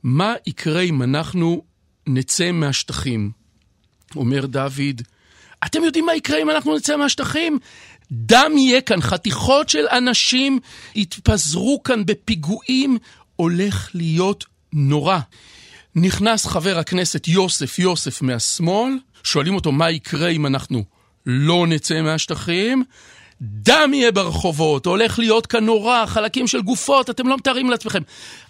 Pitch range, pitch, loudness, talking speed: 145-235 Hz, 180 Hz, -18 LUFS, 120 wpm